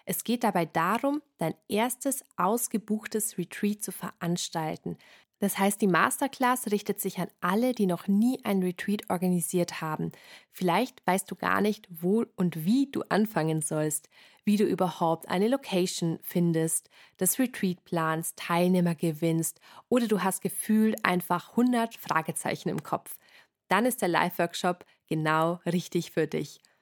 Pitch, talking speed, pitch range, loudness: 185 Hz, 145 wpm, 170-215 Hz, -28 LUFS